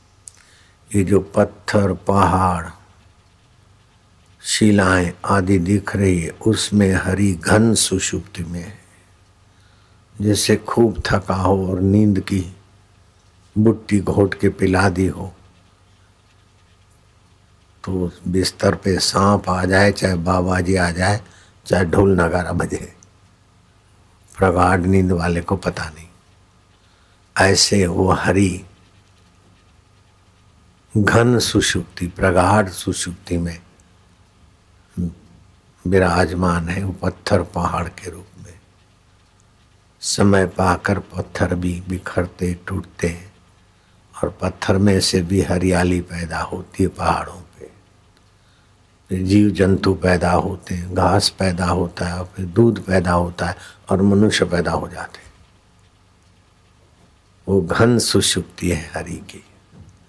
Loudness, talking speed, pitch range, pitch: -18 LUFS, 110 wpm, 90-100 Hz, 95 Hz